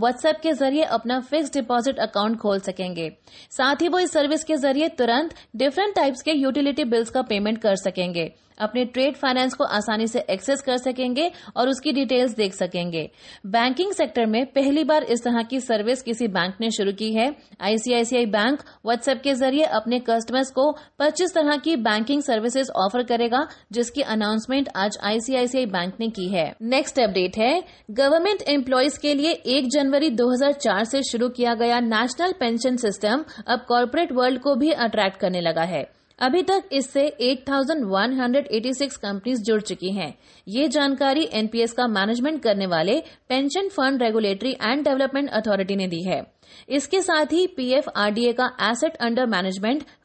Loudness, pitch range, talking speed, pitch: -22 LUFS, 220-280 Hz, 165 wpm, 250 Hz